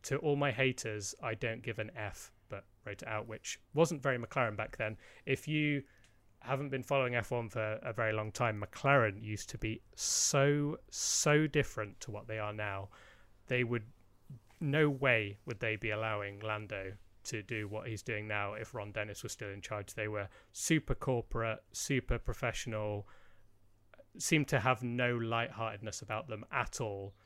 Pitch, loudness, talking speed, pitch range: 110 Hz, -35 LUFS, 175 wpm, 105-130 Hz